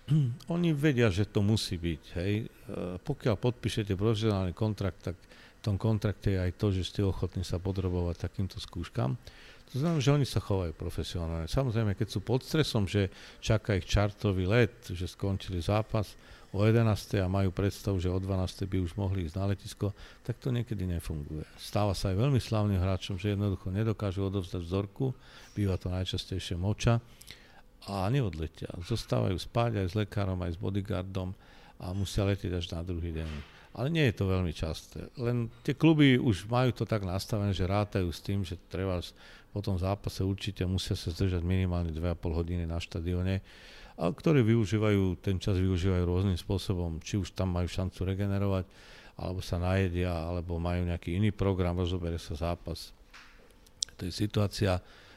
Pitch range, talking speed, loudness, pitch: 90-110 Hz, 170 wpm, -31 LUFS, 100 Hz